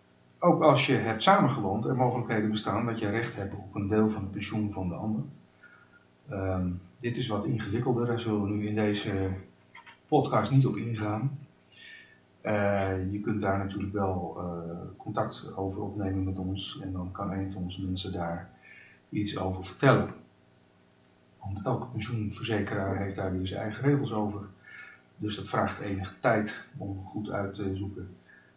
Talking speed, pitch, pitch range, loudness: 165 wpm, 100 Hz, 95-110 Hz, -30 LUFS